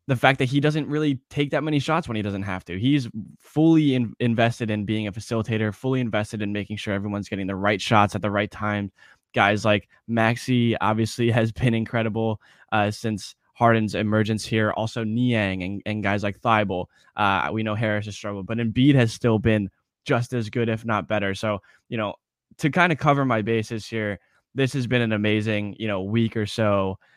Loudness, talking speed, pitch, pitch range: -23 LUFS, 205 wpm, 110 Hz, 105-120 Hz